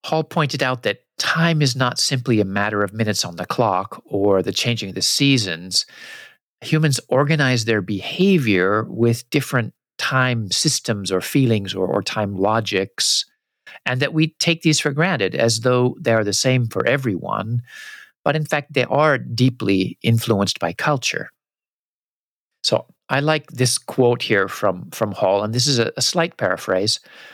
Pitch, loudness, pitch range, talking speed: 125 Hz, -19 LUFS, 105-145 Hz, 165 wpm